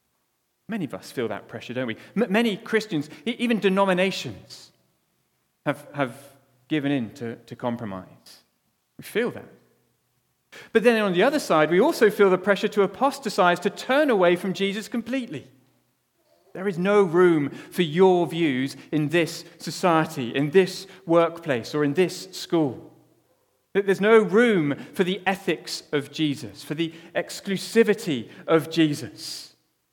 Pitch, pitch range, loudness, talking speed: 175 Hz, 145-200 Hz, -23 LUFS, 140 wpm